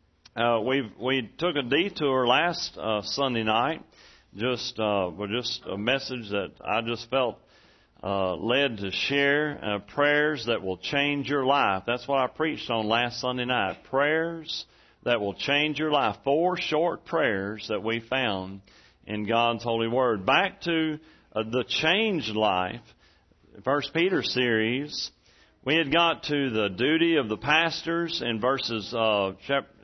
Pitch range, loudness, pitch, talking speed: 110-145 Hz, -26 LUFS, 125 Hz, 155 wpm